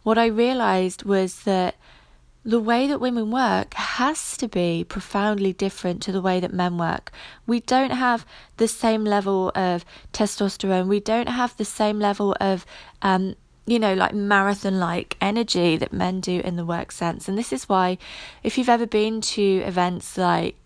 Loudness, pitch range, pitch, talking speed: -23 LUFS, 185-225 Hz, 200 Hz, 175 wpm